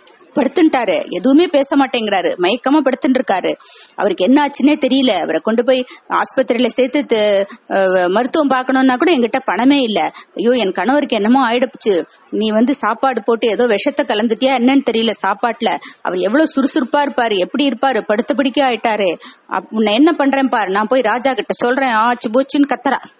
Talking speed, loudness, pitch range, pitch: 145 wpm, -15 LUFS, 220-275 Hz, 255 Hz